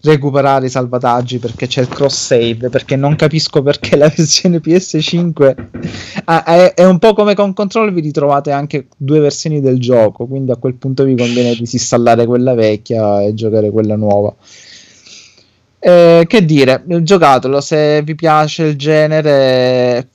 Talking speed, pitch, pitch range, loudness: 155 wpm, 140 Hz, 125-155 Hz, -11 LUFS